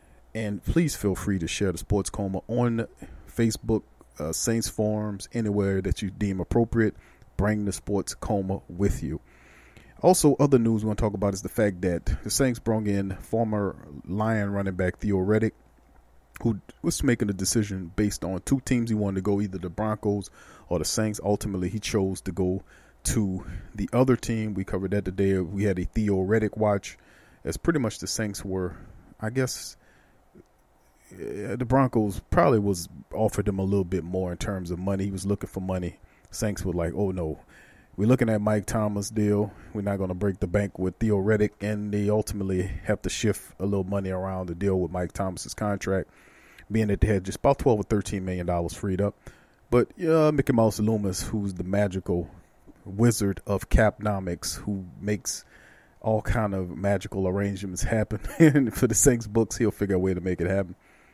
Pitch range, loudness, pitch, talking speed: 95-110 Hz, -26 LUFS, 100 Hz, 185 wpm